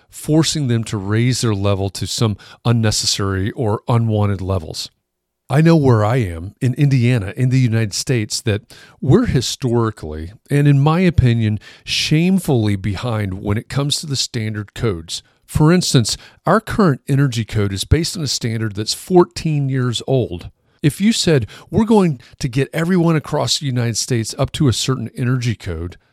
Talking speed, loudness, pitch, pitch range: 165 wpm, -17 LUFS, 120 Hz, 105-140 Hz